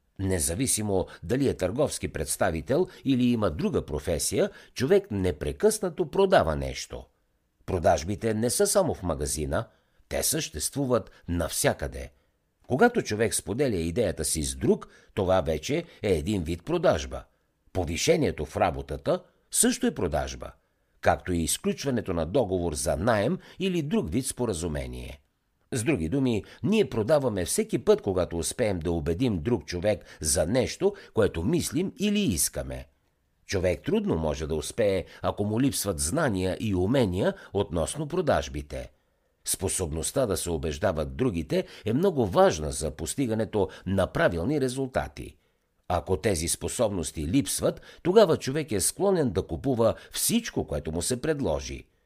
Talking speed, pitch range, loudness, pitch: 130 wpm, 80-135 Hz, -27 LUFS, 95 Hz